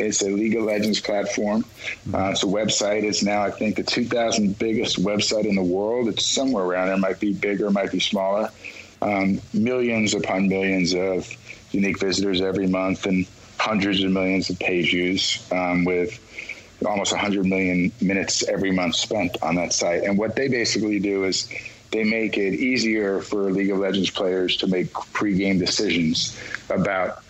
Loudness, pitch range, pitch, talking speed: -22 LUFS, 95-105 Hz, 100 Hz, 175 wpm